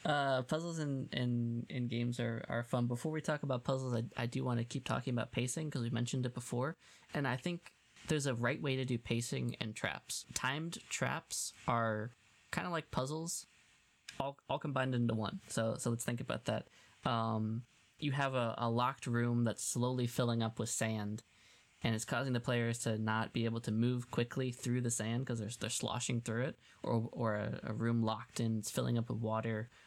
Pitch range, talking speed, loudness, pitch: 115-130 Hz, 205 wpm, -38 LUFS, 120 Hz